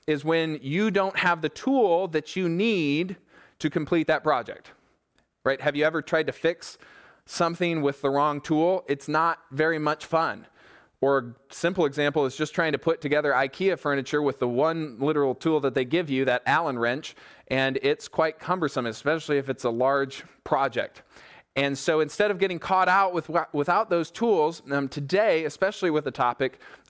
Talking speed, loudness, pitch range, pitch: 180 wpm, -25 LUFS, 140-170 Hz, 155 Hz